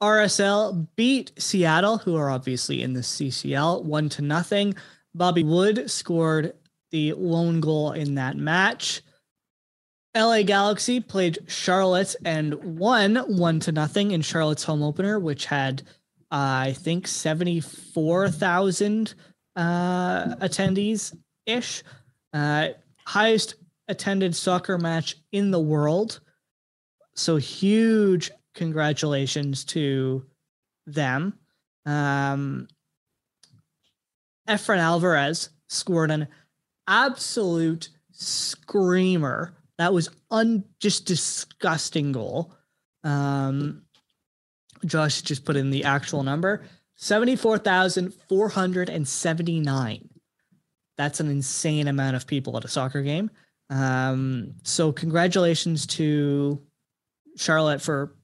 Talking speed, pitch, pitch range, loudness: 100 wpm, 165 Hz, 145-190 Hz, -24 LUFS